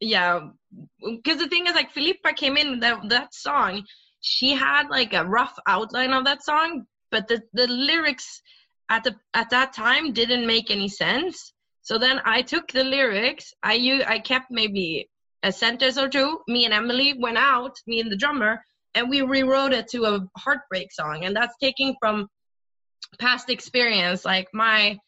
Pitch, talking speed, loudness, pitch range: 245 Hz, 175 wpm, -22 LUFS, 215-270 Hz